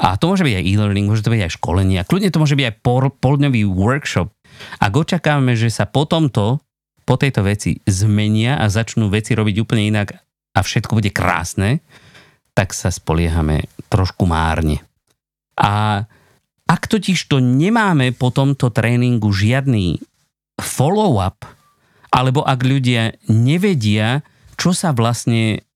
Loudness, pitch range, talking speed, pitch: -17 LUFS, 105-135 Hz, 145 wpm, 115 Hz